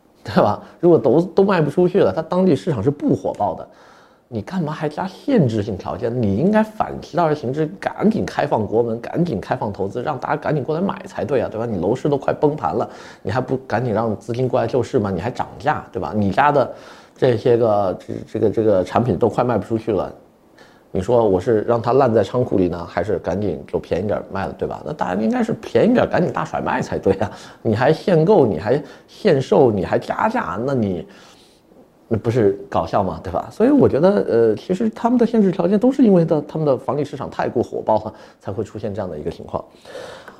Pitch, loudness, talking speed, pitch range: 135 Hz, -19 LUFS, 325 characters per minute, 115-185 Hz